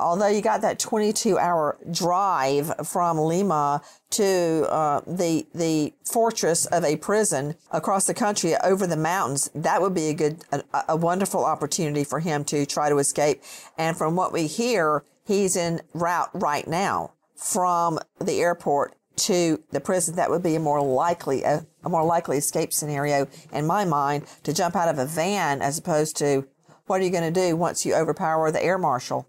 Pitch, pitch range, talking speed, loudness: 165 Hz, 150-180 Hz, 185 wpm, -24 LUFS